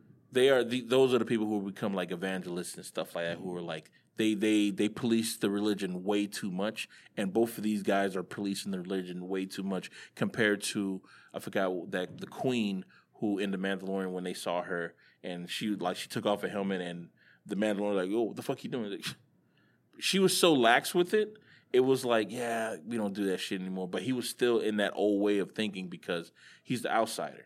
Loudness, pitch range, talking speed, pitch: -31 LUFS, 95-110 Hz, 225 wpm, 100 Hz